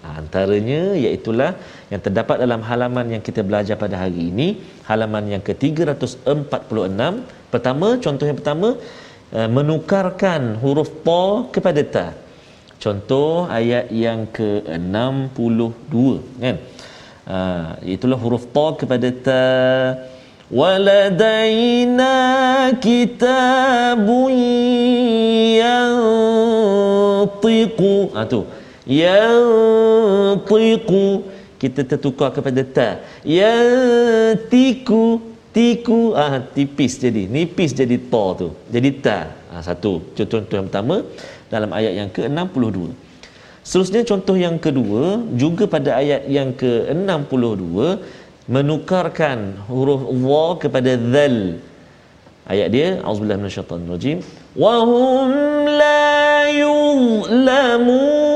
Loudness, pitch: -17 LUFS, 150 Hz